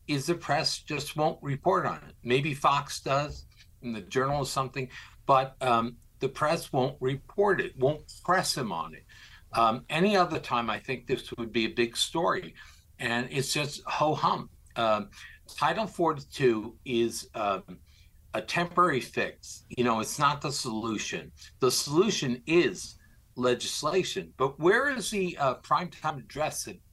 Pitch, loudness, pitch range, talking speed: 130 Hz, -29 LUFS, 115-155 Hz, 160 wpm